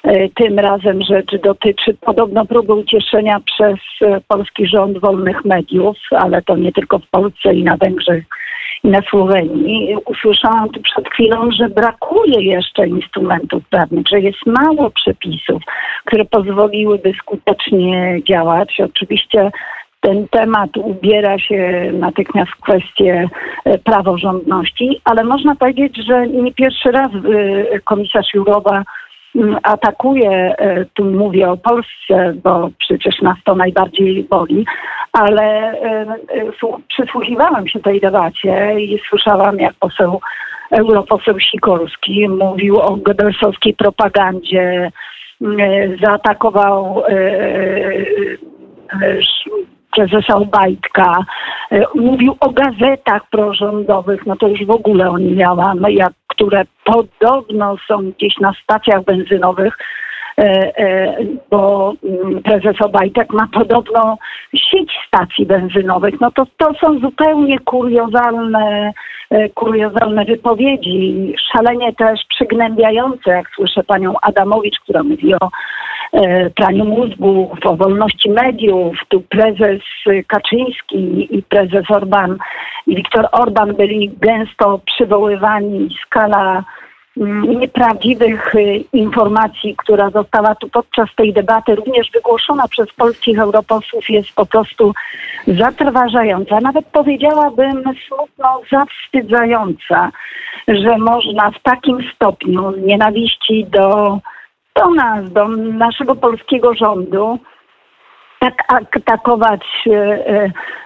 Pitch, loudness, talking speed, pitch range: 210 Hz, -13 LUFS, 105 wpm, 195-235 Hz